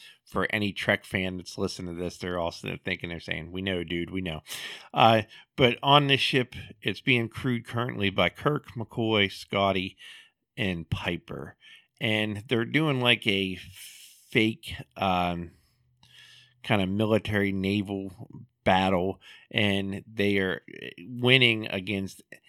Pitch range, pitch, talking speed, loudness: 95-120 Hz, 100 Hz, 135 wpm, -27 LUFS